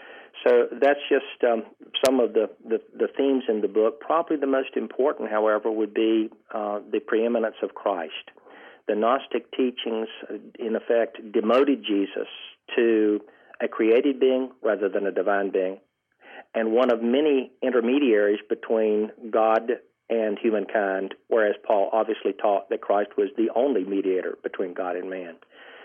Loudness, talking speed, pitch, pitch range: -24 LUFS, 150 wpm, 110 Hz, 105-135 Hz